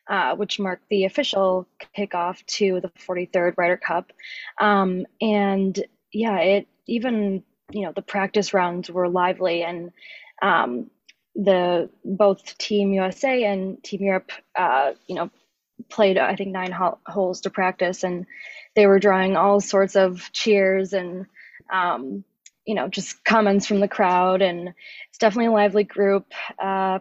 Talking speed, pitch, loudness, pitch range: 145 wpm, 195 Hz, -22 LUFS, 185-205 Hz